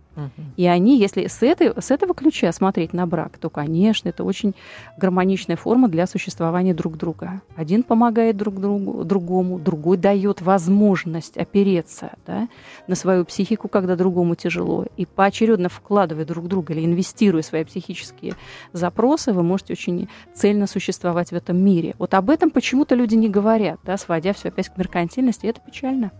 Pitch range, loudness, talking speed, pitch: 175-210 Hz, -20 LUFS, 165 wpm, 190 Hz